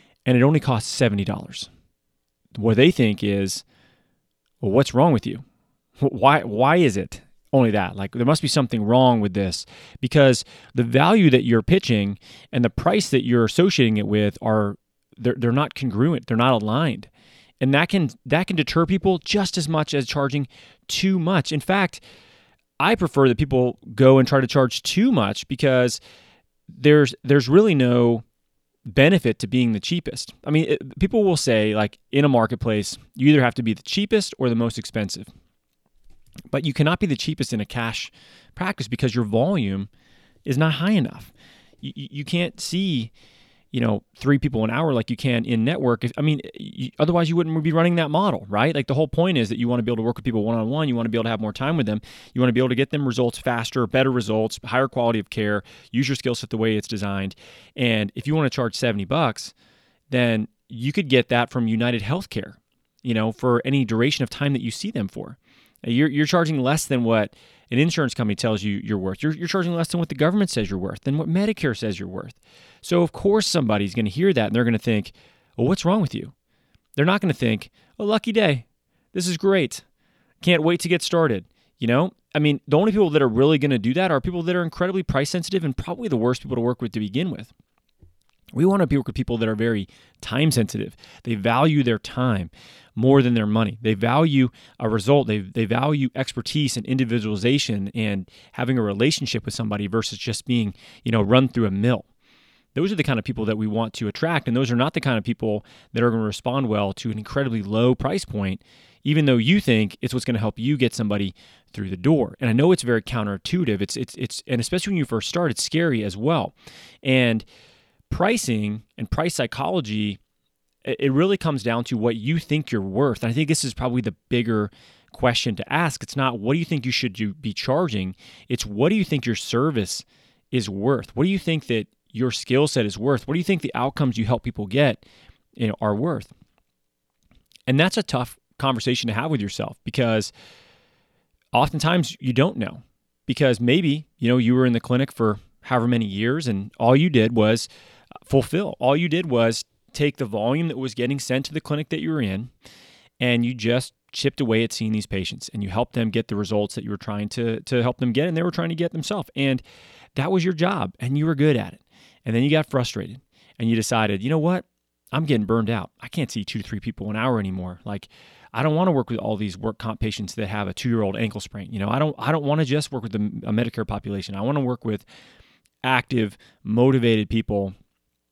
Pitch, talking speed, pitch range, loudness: 125 Hz, 225 wpm, 110-150 Hz, -22 LUFS